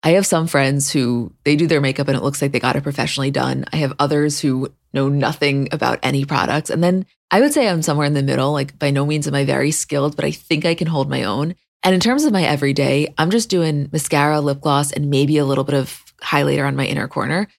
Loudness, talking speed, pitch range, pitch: -18 LUFS, 260 wpm, 140-160 Hz, 145 Hz